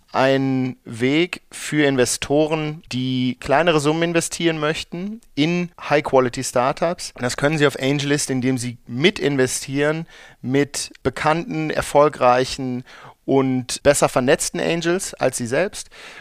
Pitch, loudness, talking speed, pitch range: 145 Hz, -20 LUFS, 120 wpm, 130-160 Hz